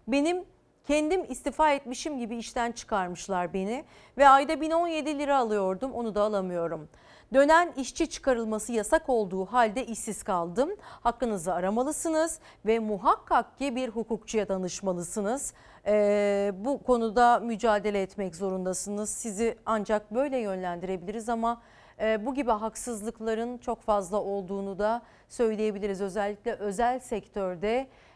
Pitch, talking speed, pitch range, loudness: 225 Hz, 115 wpm, 205-255 Hz, -28 LUFS